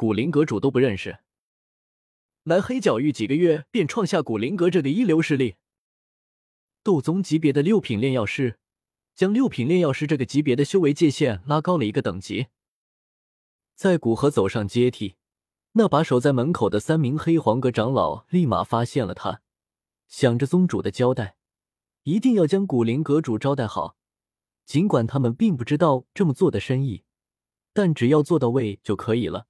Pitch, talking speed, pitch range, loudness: 140 Hz, 260 characters per minute, 110-165 Hz, -22 LUFS